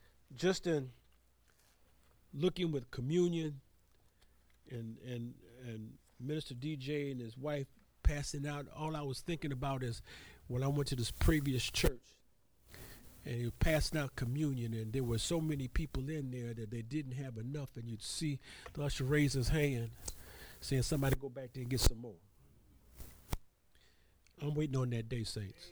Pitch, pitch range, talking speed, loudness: 130 Hz, 115-145 Hz, 165 wpm, -38 LUFS